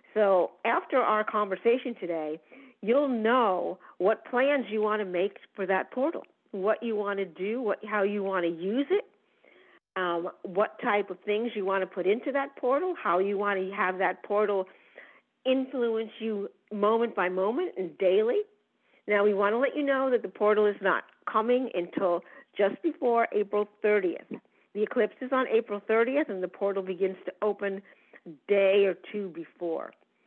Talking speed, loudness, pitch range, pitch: 175 wpm, -28 LUFS, 195-245 Hz, 210 Hz